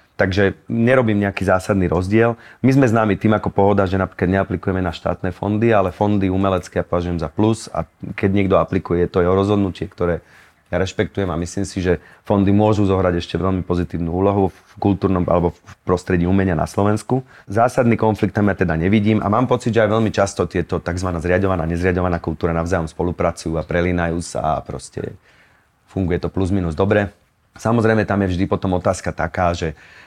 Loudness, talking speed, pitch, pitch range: -19 LUFS, 180 wpm, 95 Hz, 90-105 Hz